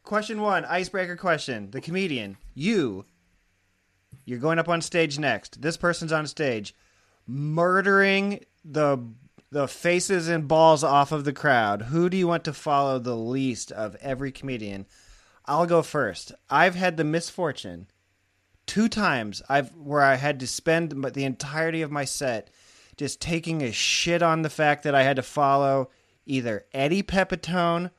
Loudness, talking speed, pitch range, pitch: -24 LUFS, 155 wpm, 125-170 Hz, 145 Hz